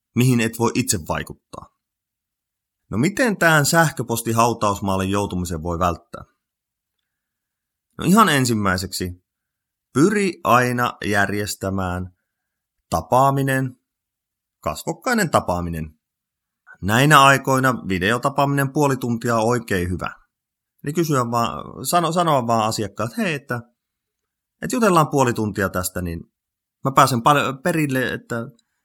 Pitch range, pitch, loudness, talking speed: 95-140 Hz, 115 Hz, -19 LUFS, 100 wpm